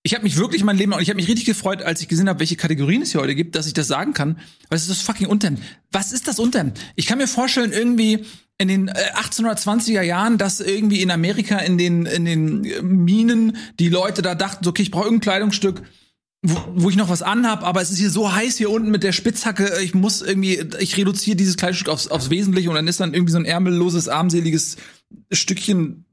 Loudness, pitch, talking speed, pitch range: -19 LUFS, 190 Hz, 230 wpm, 175-210 Hz